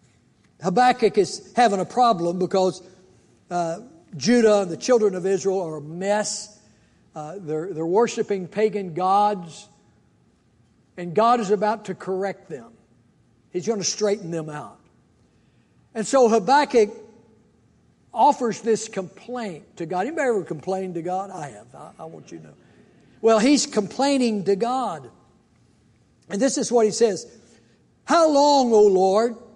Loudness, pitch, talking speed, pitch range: -21 LUFS, 200 Hz, 145 wpm, 175-230 Hz